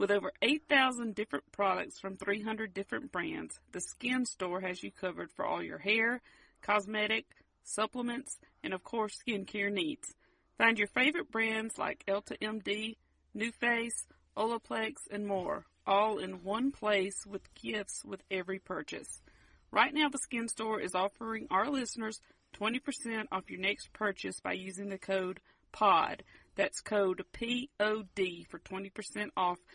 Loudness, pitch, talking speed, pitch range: -34 LUFS, 210 Hz, 145 wpm, 195-230 Hz